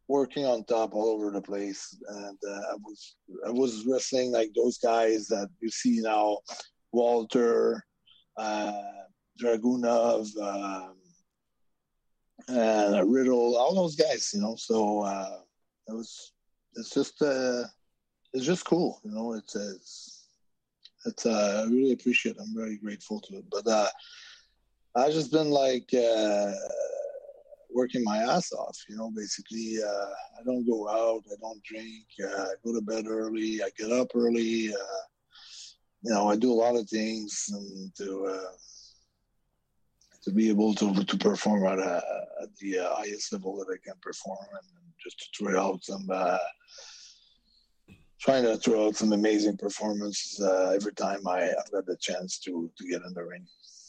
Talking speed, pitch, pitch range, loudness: 160 wpm, 110 Hz, 105-125 Hz, -29 LUFS